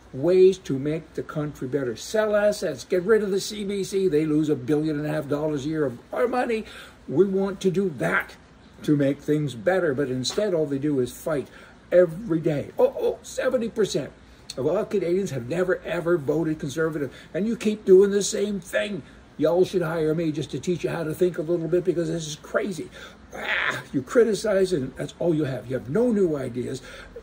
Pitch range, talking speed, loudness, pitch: 150-195 Hz, 205 wpm, -24 LUFS, 170 Hz